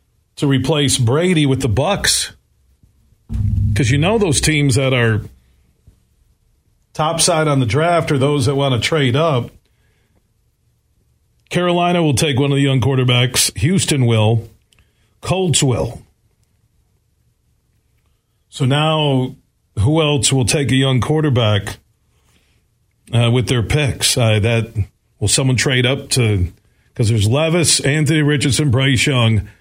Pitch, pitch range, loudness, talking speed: 130 Hz, 115-150 Hz, -15 LUFS, 130 wpm